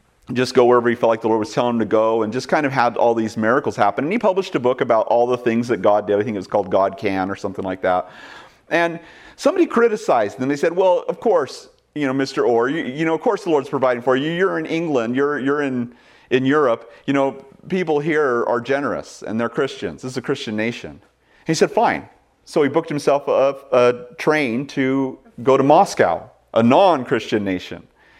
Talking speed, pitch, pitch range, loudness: 230 wpm, 130 Hz, 115-150 Hz, -19 LUFS